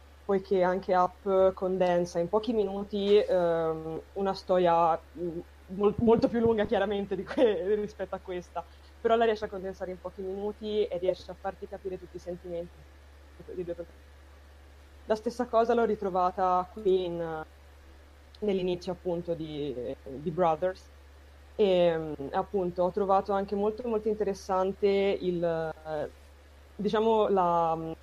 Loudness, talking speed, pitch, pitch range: -29 LUFS, 130 wpm, 185 Hz, 165-200 Hz